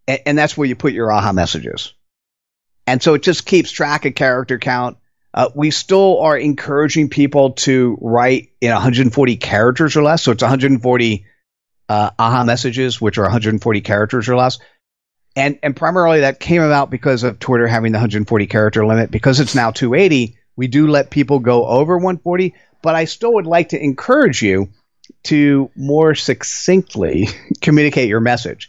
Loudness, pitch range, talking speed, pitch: -14 LUFS, 120-150 Hz, 170 wpm, 130 Hz